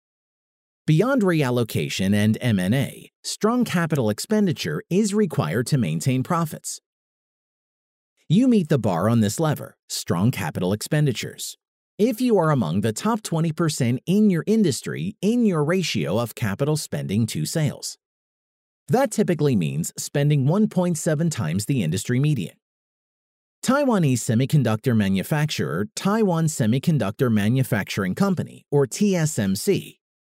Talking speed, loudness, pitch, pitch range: 115 wpm, -22 LUFS, 150 Hz, 120-190 Hz